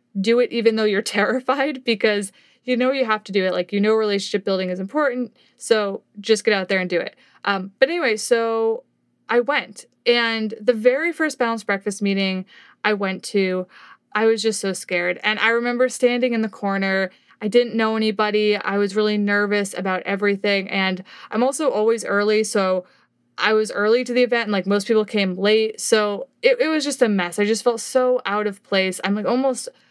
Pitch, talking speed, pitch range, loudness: 215 Hz, 205 wpm, 200-240 Hz, -20 LUFS